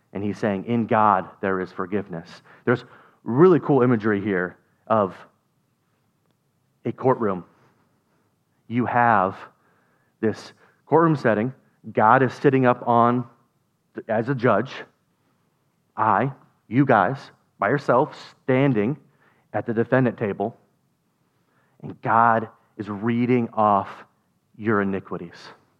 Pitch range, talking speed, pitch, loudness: 100-125 Hz, 105 wpm, 115 Hz, -22 LUFS